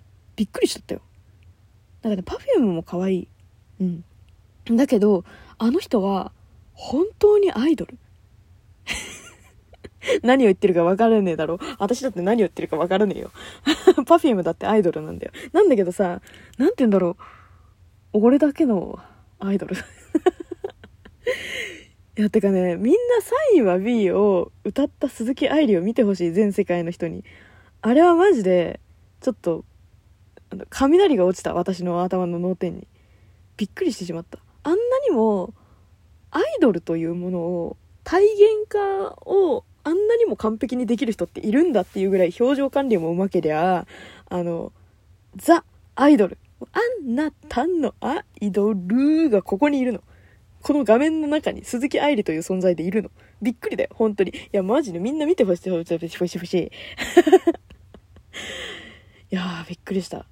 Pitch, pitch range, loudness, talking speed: 205 Hz, 175-290 Hz, -21 LUFS, 310 characters per minute